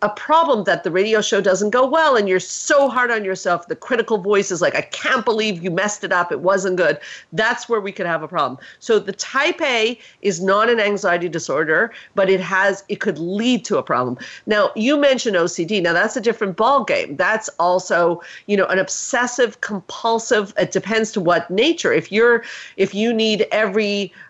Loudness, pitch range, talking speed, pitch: -18 LUFS, 190-235 Hz, 205 wpm, 205 Hz